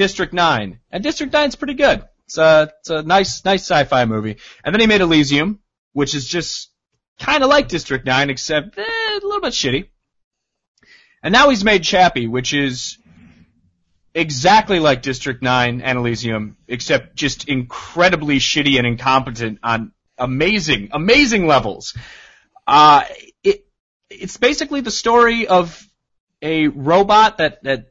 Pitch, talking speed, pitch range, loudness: 155 Hz, 145 wpm, 130-210 Hz, -16 LUFS